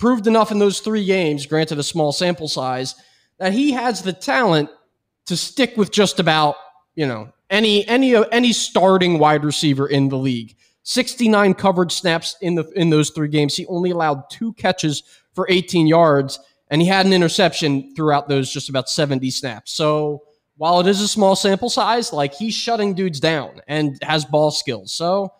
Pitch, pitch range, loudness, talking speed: 165 Hz, 145-195 Hz, -18 LUFS, 185 wpm